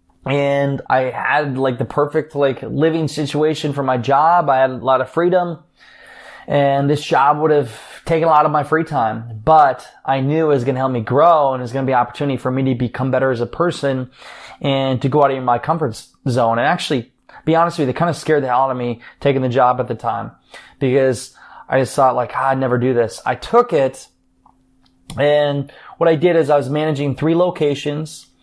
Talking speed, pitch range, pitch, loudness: 230 wpm, 130-150 Hz, 140 Hz, -17 LUFS